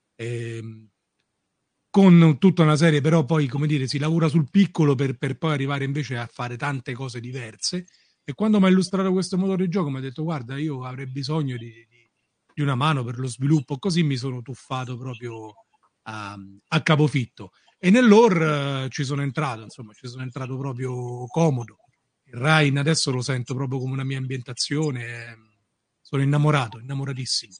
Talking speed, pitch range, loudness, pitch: 175 wpm, 125-155 Hz, -22 LUFS, 135 Hz